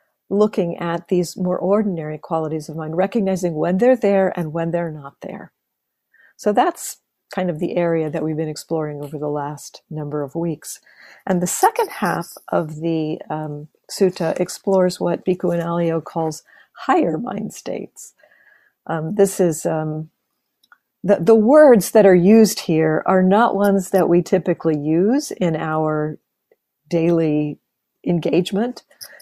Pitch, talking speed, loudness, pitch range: 175 Hz, 150 wpm, -19 LUFS, 160-195 Hz